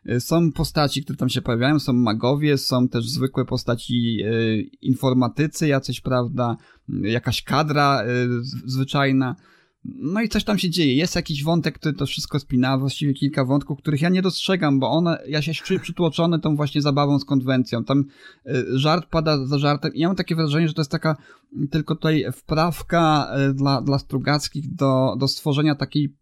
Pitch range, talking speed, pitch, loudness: 130-160 Hz, 165 wpm, 145 Hz, -21 LUFS